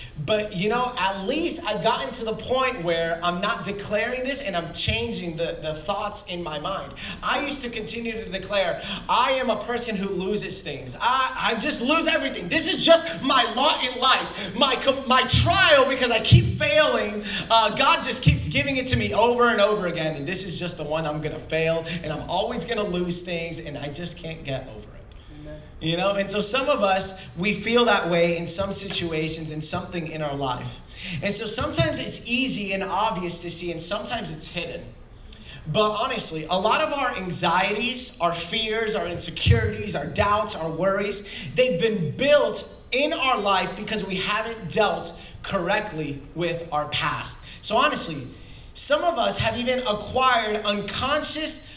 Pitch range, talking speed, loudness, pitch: 170-240 Hz, 190 wpm, -23 LUFS, 200 Hz